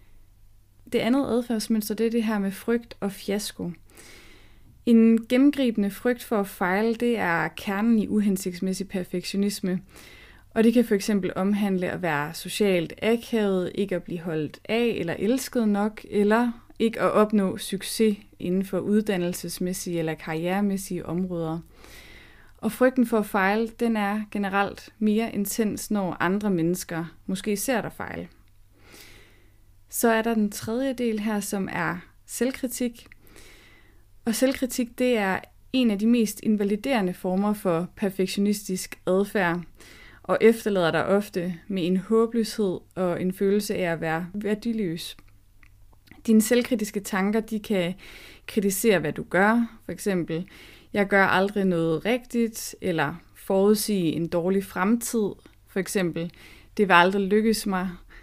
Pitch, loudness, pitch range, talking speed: 200 Hz, -25 LUFS, 175-220 Hz, 135 wpm